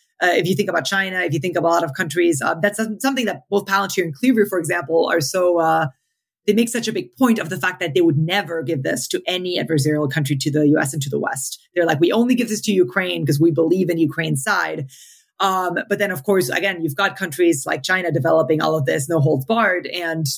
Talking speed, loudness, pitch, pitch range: 255 wpm, -19 LUFS, 175 Hz, 160-195 Hz